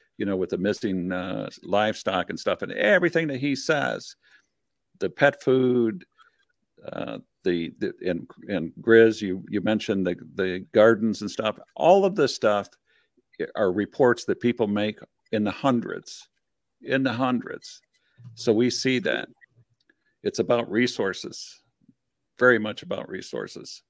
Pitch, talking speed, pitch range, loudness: 115 Hz, 145 wpm, 105-130 Hz, -24 LUFS